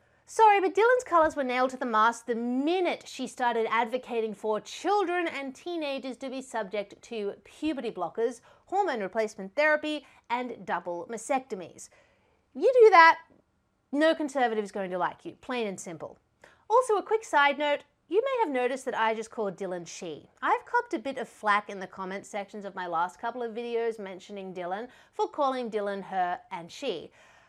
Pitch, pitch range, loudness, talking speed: 240 Hz, 210-305 Hz, -28 LUFS, 180 wpm